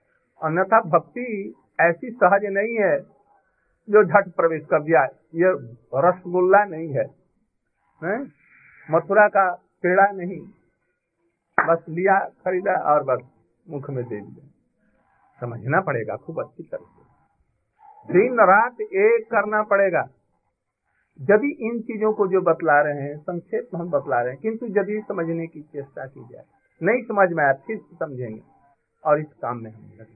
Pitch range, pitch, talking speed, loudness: 150-205 Hz, 180 Hz, 140 wpm, -21 LUFS